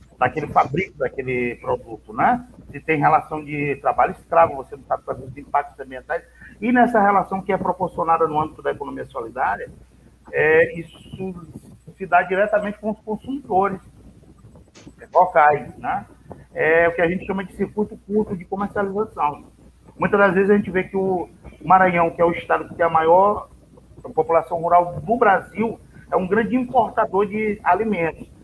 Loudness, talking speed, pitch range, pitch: -20 LUFS, 160 wpm, 165-210 Hz, 185 Hz